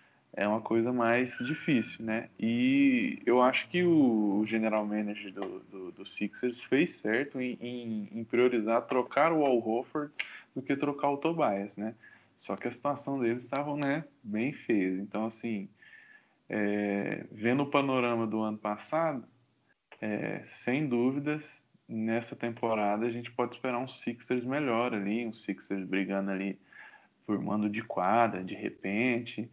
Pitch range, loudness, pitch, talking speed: 105-135 Hz, -31 LUFS, 120 Hz, 150 wpm